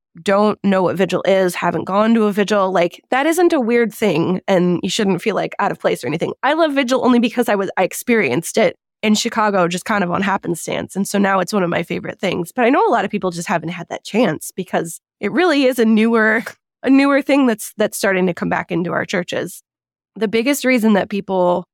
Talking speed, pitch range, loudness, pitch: 240 wpm, 185-230 Hz, -17 LUFS, 200 Hz